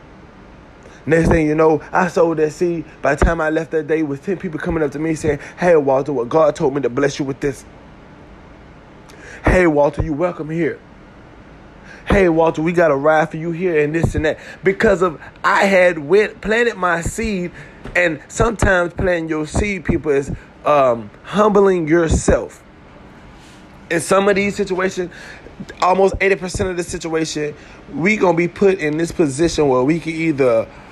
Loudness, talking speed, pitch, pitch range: -17 LUFS, 180 wpm, 165 Hz, 150-180 Hz